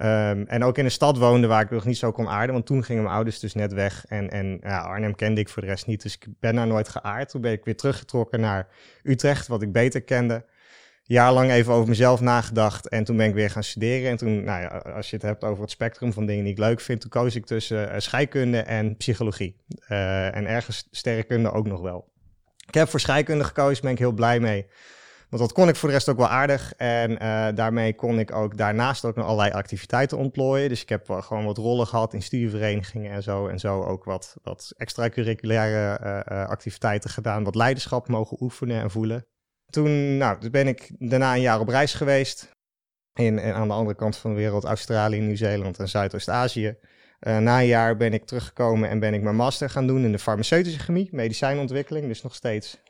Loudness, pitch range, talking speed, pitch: -24 LUFS, 105-125 Hz, 230 wpm, 115 Hz